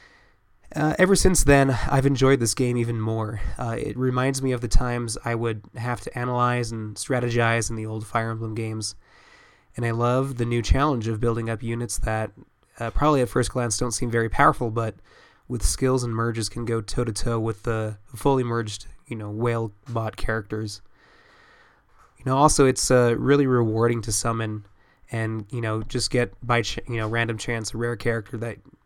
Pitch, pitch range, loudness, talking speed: 115 Hz, 110-125 Hz, -24 LUFS, 195 wpm